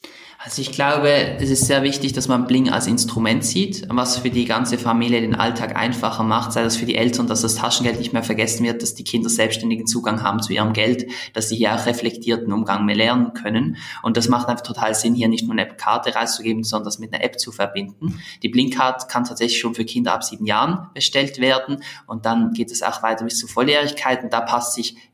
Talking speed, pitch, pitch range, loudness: 230 wpm, 115 Hz, 115-125 Hz, -20 LUFS